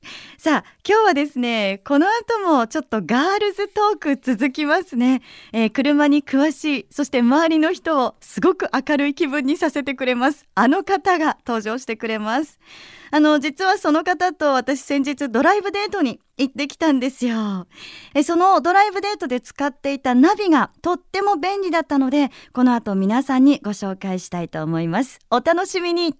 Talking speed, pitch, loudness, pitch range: 340 characters per minute, 290 Hz, -19 LUFS, 250-335 Hz